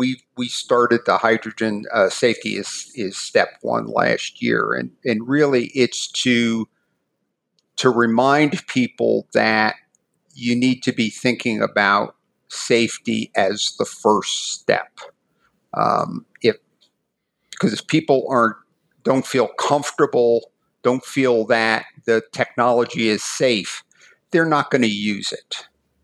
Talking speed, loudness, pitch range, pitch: 125 wpm, -19 LUFS, 110-130 Hz, 120 Hz